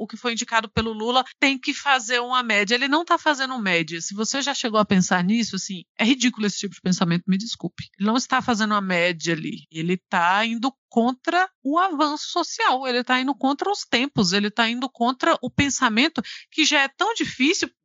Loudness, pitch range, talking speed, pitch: -22 LUFS, 205-275 Hz, 215 wpm, 245 Hz